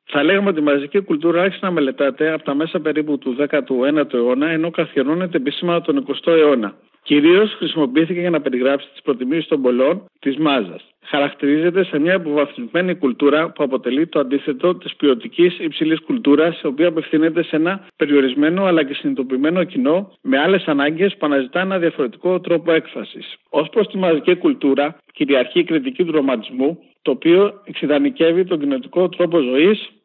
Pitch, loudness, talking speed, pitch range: 160 Hz, -17 LUFS, 165 wpm, 145-185 Hz